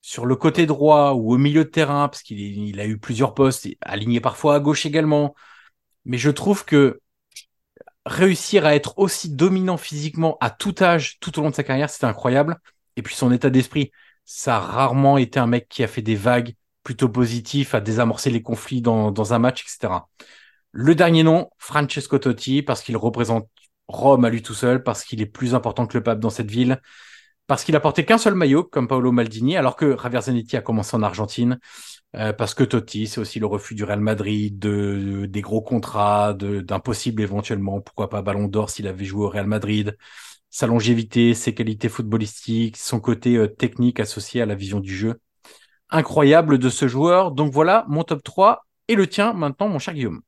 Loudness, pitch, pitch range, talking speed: -20 LUFS, 125 Hz, 110-145 Hz, 205 wpm